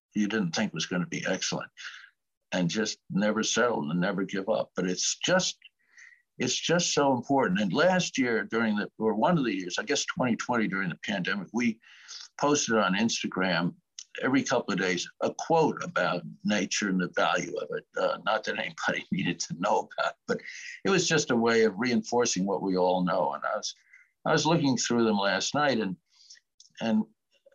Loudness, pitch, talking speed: -28 LUFS, 120 Hz, 190 wpm